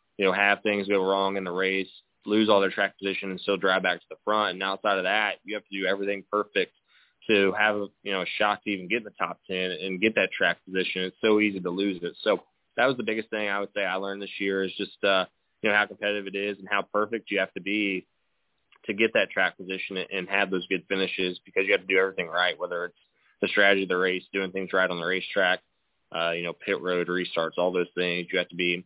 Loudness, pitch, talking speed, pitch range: -26 LUFS, 95 Hz, 265 wpm, 95-100 Hz